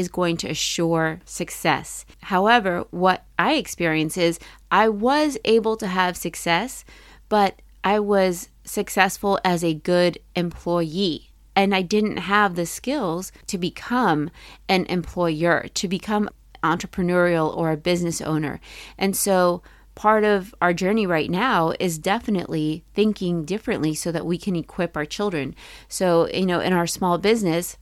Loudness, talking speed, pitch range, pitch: -22 LUFS, 145 wpm, 170-200 Hz, 180 Hz